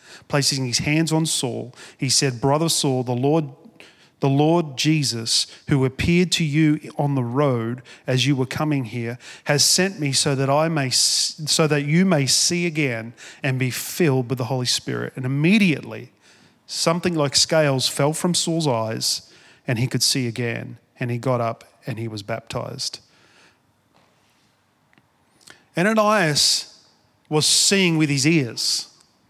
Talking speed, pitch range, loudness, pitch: 155 wpm, 125-155 Hz, -20 LUFS, 140 Hz